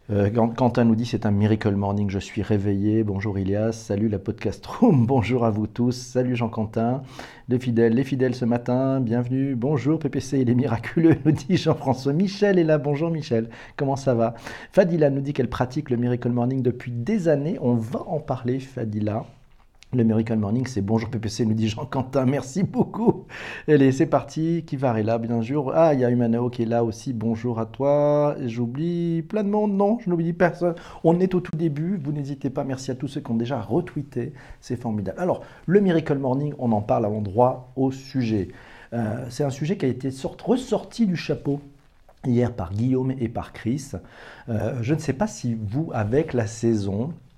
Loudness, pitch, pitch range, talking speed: -23 LUFS, 130 Hz, 115-150 Hz, 195 wpm